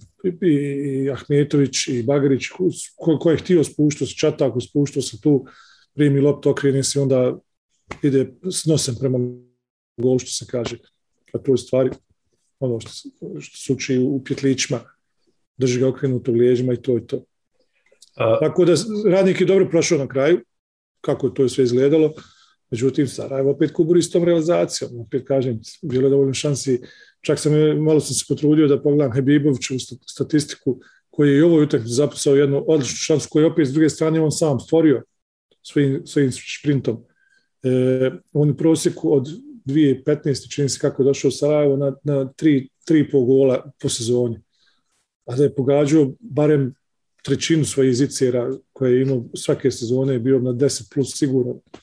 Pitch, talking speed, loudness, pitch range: 140 Hz, 165 wpm, -19 LUFS, 130-150 Hz